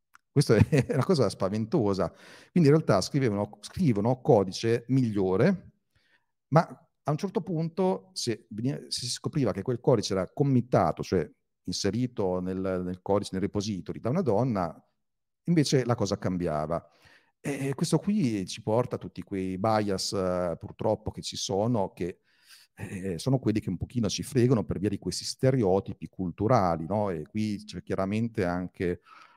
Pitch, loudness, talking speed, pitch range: 105 Hz, -28 LUFS, 150 wpm, 95-130 Hz